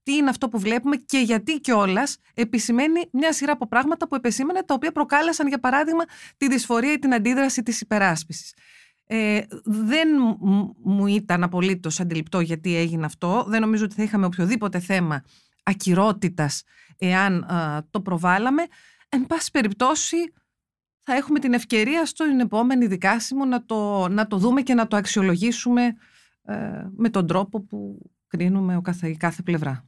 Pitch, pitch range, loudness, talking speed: 220 Hz, 190-270 Hz, -22 LUFS, 155 wpm